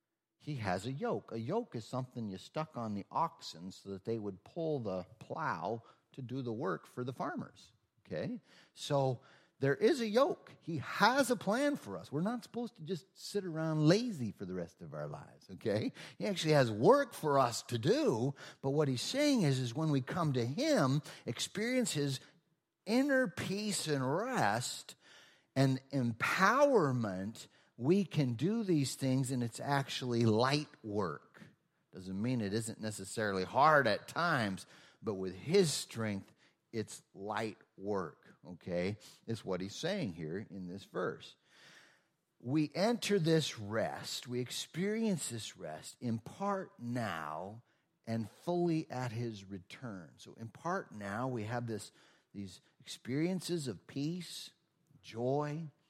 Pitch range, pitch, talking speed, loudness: 115-165 Hz, 135 Hz, 155 wpm, -35 LUFS